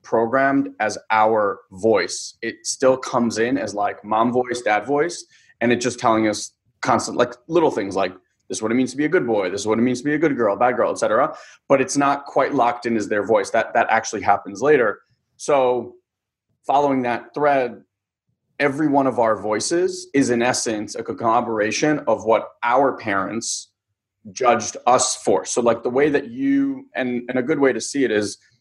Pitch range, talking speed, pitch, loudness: 110-140 Hz, 205 wpm, 120 Hz, -20 LUFS